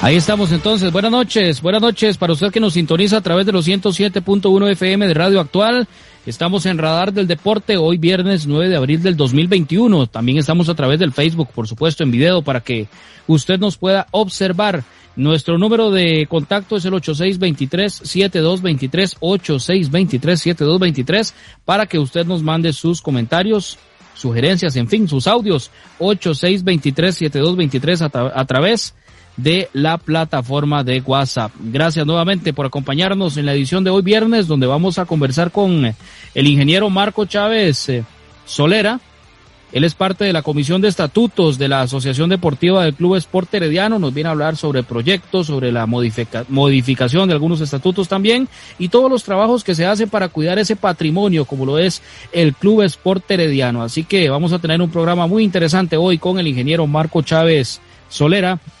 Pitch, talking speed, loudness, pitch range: 170 Hz, 165 wpm, -15 LUFS, 145-195 Hz